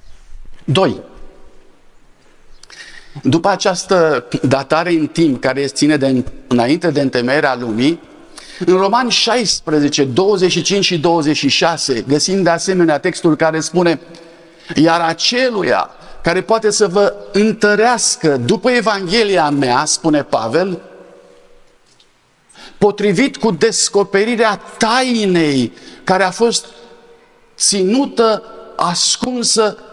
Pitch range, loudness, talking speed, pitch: 155-225 Hz, -14 LUFS, 95 wpm, 185 Hz